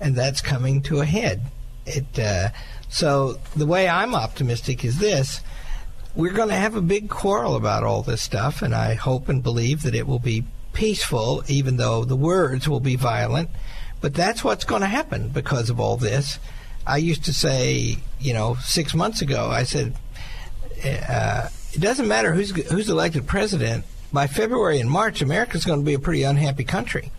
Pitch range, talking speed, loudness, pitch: 120-155 Hz, 185 wpm, -22 LUFS, 135 Hz